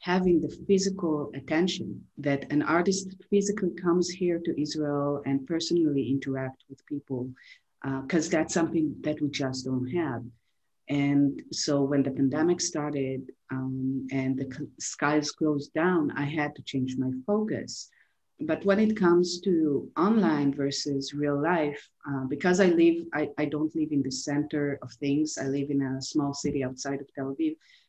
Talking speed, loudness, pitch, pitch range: 165 wpm, -28 LUFS, 145 Hz, 135-170 Hz